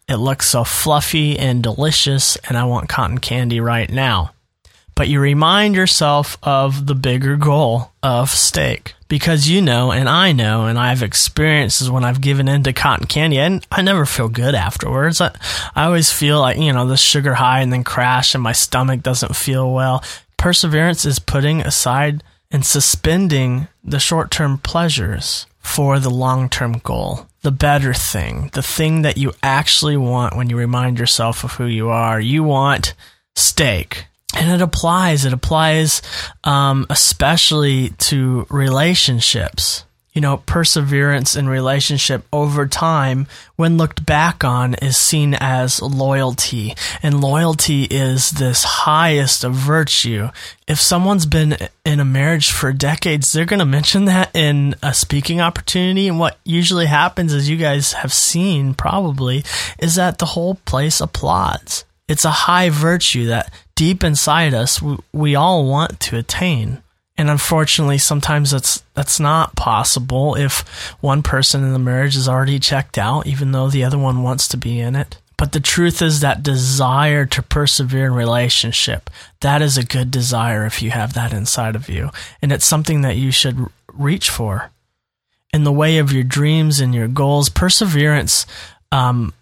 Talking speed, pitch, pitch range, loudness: 165 wpm, 140 Hz, 125-155 Hz, -15 LUFS